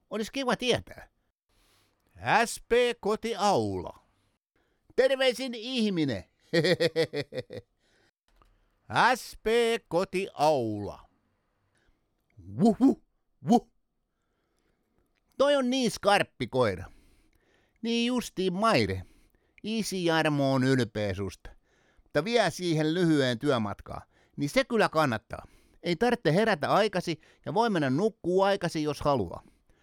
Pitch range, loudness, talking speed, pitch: 145-230 Hz, -27 LUFS, 90 wpm, 185 Hz